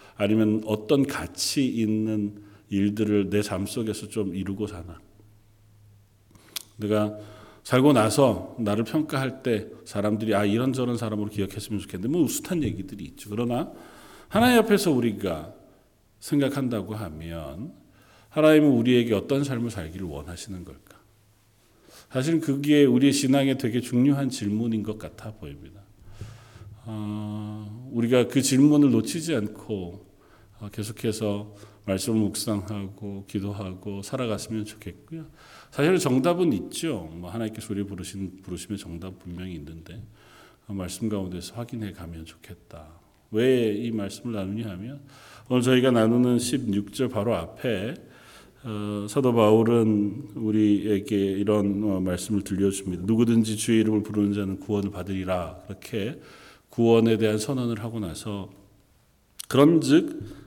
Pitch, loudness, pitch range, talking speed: 105 Hz, -25 LUFS, 100-120 Hz, 290 characters per minute